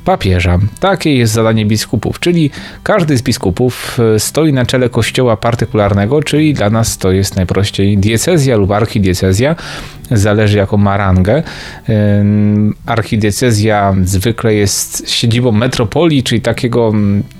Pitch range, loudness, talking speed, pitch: 100-125 Hz, -12 LUFS, 115 wpm, 110 Hz